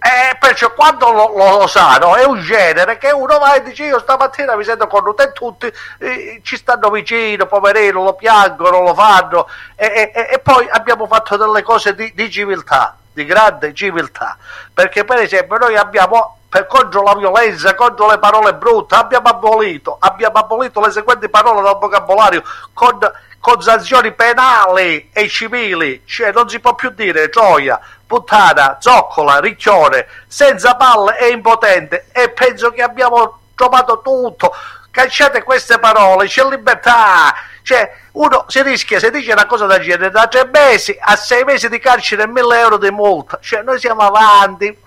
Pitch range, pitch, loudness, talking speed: 205-255 Hz, 230 Hz, -10 LUFS, 170 wpm